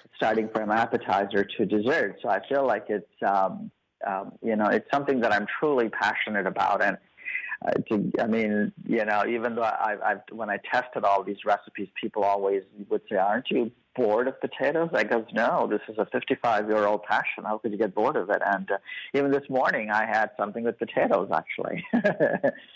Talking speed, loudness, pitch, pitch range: 195 wpm, -26 LUFS, 105 Hz, 100-115 Hz